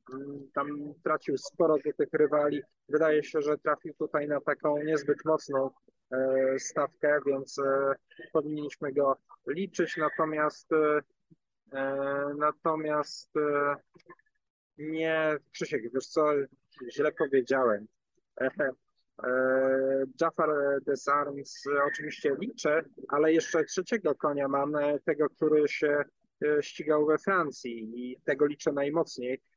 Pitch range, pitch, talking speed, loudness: 140-155 Hz, 150 Hz, 110 wpm, -29 LUFS